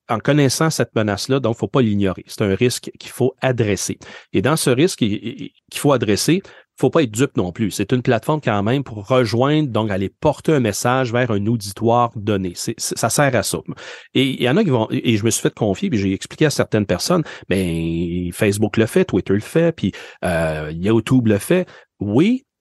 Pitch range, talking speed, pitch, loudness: 100-135 Hz, 225 wpm, 115 Hz, -19 LUFS